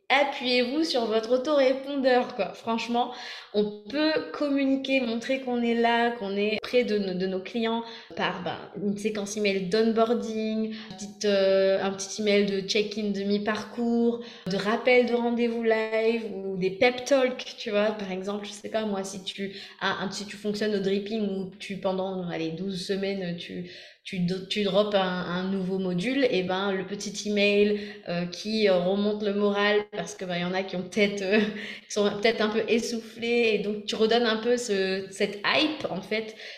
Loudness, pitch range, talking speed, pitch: -27 LUFS, 195-230 Hz, 180 wpm, 210 Hz